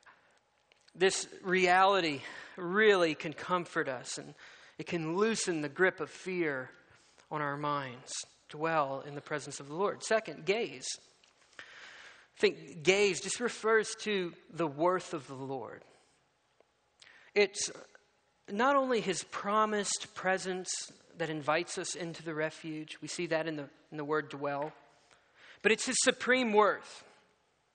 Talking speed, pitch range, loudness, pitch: 135 wpm, 155-205 Hz, -32 LUFS, 175 Hz